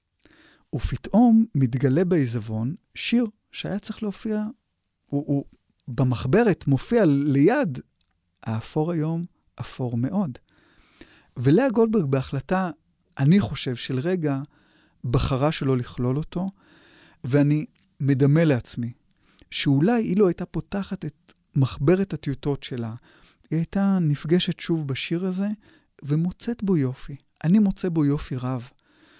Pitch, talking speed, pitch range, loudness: 155 Hz, 110 wpm, 135-190 Hz, -24 LUFS